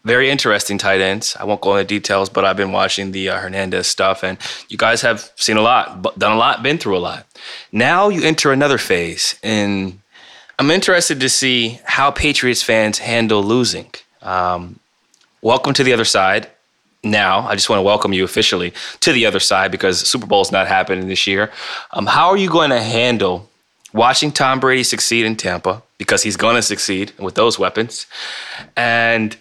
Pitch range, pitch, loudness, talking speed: 95-125 Hz, 105 Hz, -15 LUFS, 190 wpm